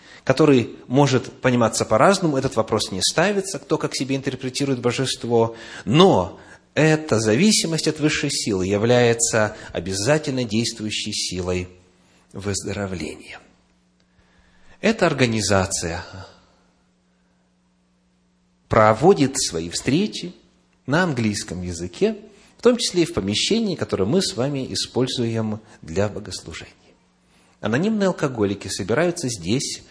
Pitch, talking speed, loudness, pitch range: 115 Hz, 100 wpm, -21 LUFS, 95-140 Hz